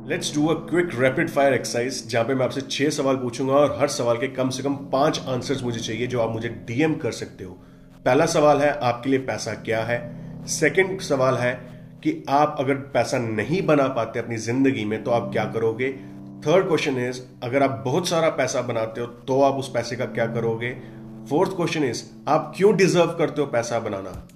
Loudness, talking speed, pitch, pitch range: -23 LUFS, 185 wpm, 130 Hz, 115-150 Hz